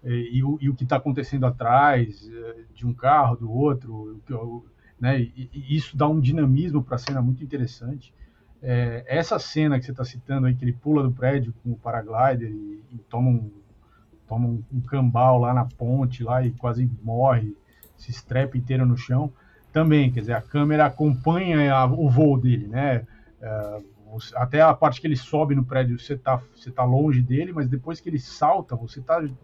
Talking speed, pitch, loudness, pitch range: 190 wpm, 125 Hz, -23 LUFS, 120-140 Hz